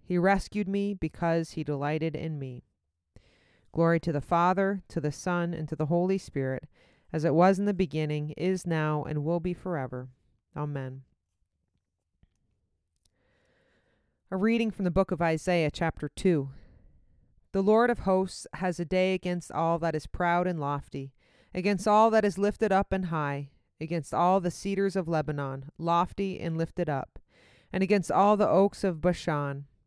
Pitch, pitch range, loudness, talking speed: 165 Hz, 140-185 Hz, -28 LUFS, 165 wpm